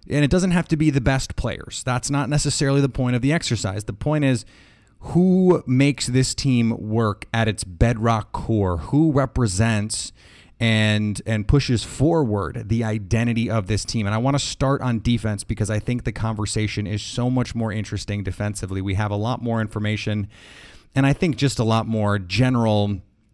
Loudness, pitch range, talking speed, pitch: -22 LUFS, 105-135 Hz, 185 wpm, 115 Hz